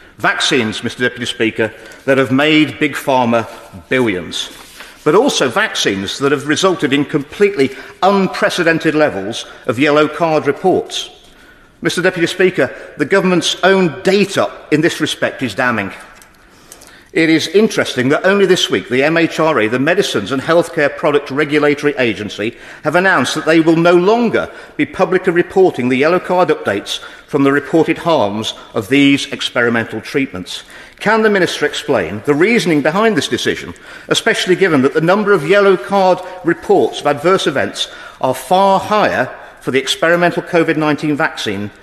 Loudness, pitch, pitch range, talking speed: -14 LUFS, 160 Hz, 135-185 Hz, 150 wpm